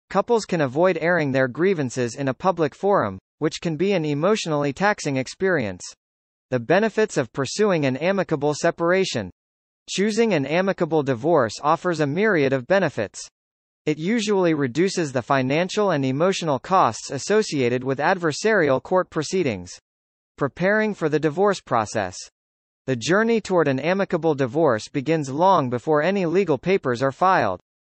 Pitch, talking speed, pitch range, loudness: 160 Hz, 140 wpm, 135-190 Hz, -22 LUFS